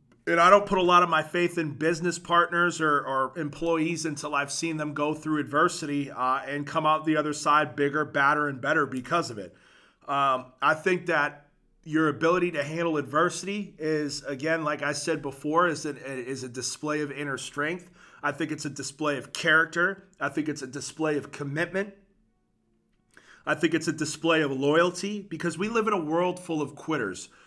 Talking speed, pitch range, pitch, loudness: 195 wpm, 145-170 Hz, 155 Hz, -26 LUFS